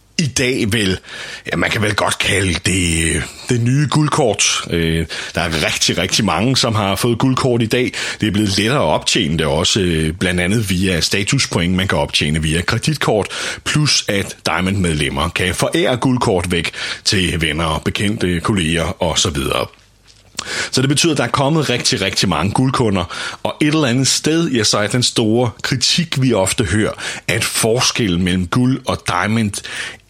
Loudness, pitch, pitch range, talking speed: -16 LUFS, 105 Hz, 90-130 Hz, 170 wpm